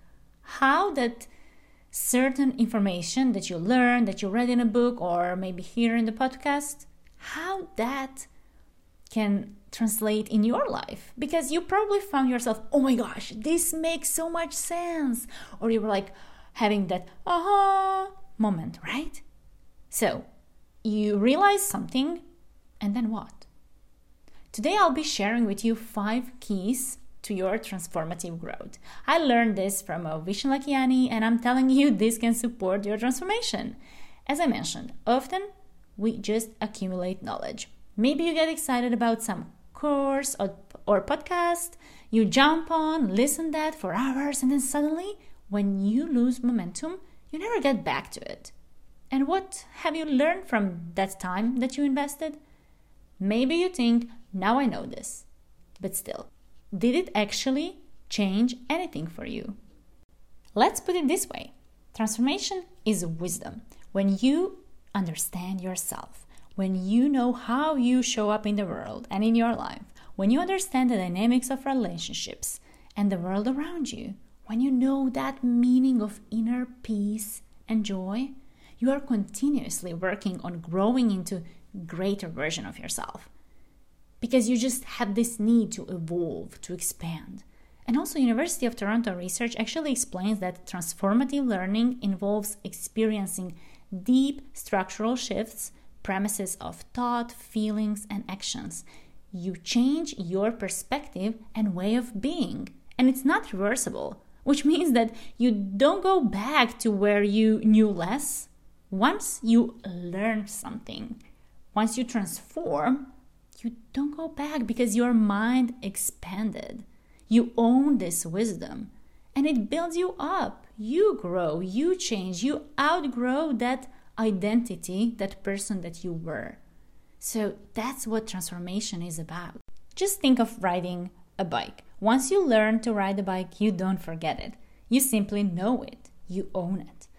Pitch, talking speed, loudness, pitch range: 230 Hz, 145 wpm, -27 LUFS, 200-270 Hz